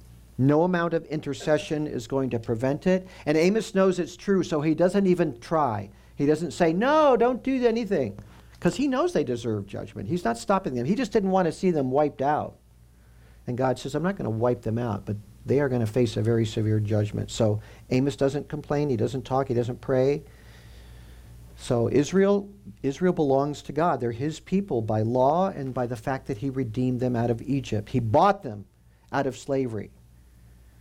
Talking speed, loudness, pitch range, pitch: 200 wpm, -25 LUFS, 110-160 Hz, 135 Hz